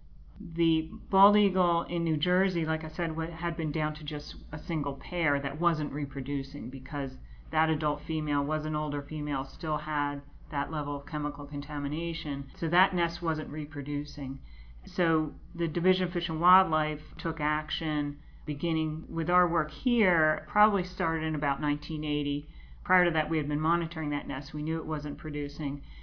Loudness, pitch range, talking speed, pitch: -30 LUFS, 145-170 Hz, 170 wpm, 155 Hz